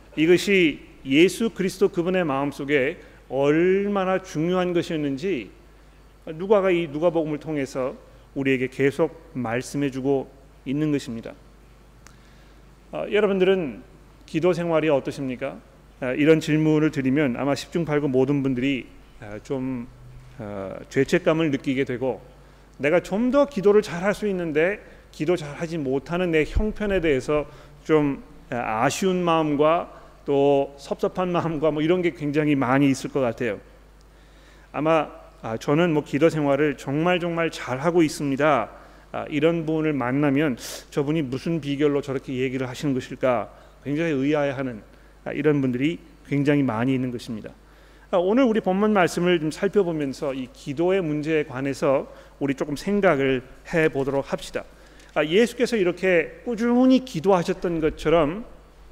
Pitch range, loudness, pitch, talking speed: 135-175 Hz, -23 LUFS, 150 Hz, 295 characters per minute